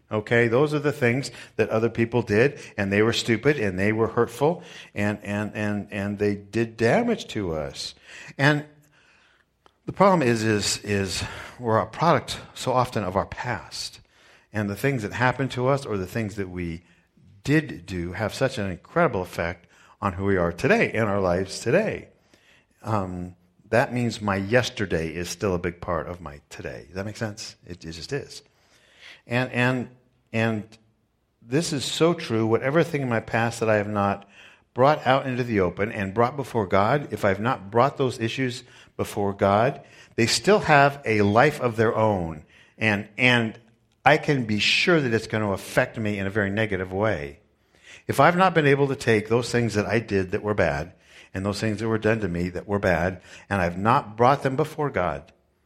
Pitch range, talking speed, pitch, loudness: 100-125 Hz, 195 wpm, 110 Hz, -24 LUFS